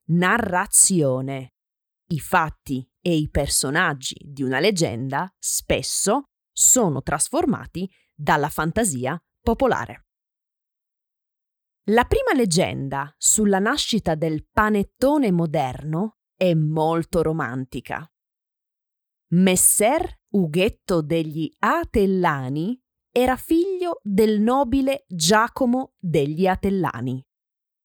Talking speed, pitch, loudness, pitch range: 80 wpm, 180 Hz, -21 LUFS, 155-220 Hz